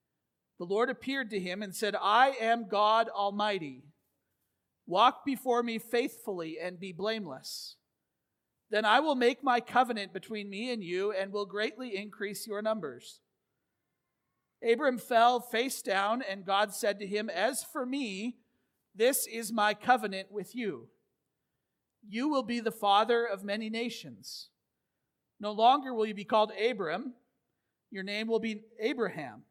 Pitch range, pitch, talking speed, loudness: 205-240 Hz, 220 Hz, 145 wpm, -31 LUFS